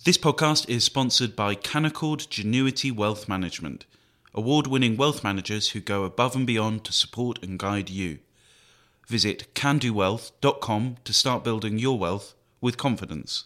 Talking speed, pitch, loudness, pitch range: 145 wpm, 115 Hz, -25 LUFS, 105-135 Hz